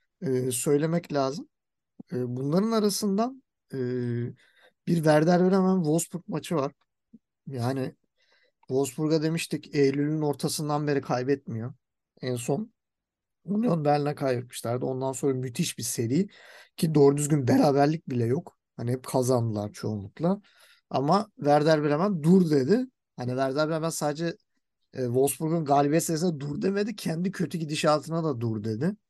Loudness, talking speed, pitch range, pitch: -27 LUFS, 120 wpm, 130-180 Hz, 150 Hz